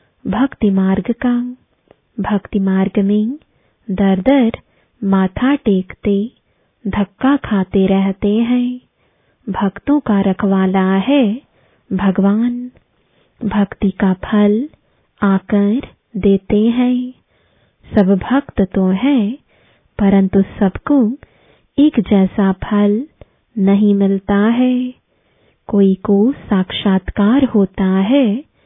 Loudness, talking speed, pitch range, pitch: -15 LUFS, 90 wpm, 195-245 Hz, 205 Hz